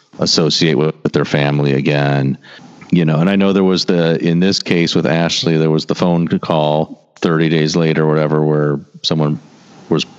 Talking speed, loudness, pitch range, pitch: 185 wpm, -14 LUFS, 75-85 Hz, 80 Hz